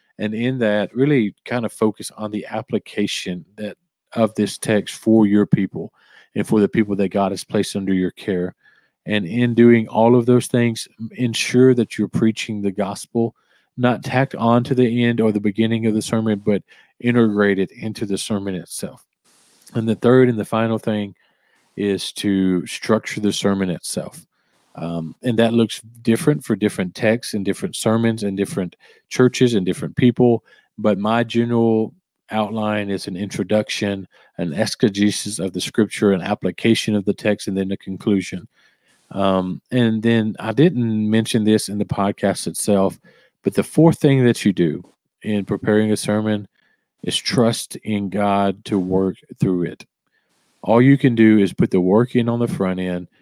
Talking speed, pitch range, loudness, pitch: 175 wpm, 100-115 Hz, -19 LUFS, 105 Hz